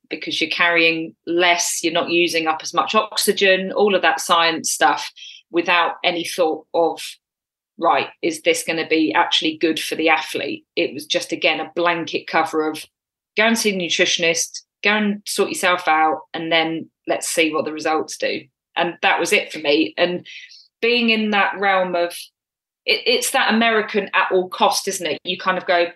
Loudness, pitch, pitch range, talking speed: -18 LUFS, 175 Hz, 165-200 Hz, 190 wpm